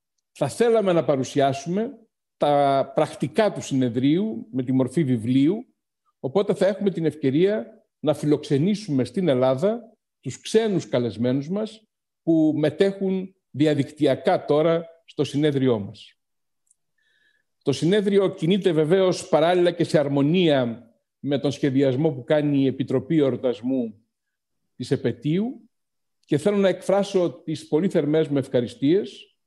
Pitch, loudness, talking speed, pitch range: 155 Hz, -22 LUFS, 120 wpm, 135-195 Hz